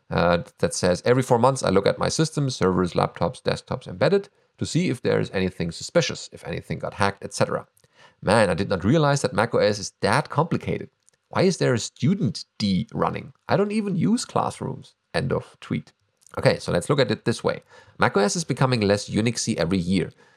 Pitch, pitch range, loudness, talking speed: 120 Hz, 95-155 Hz, -23 LUFS, 195 wpm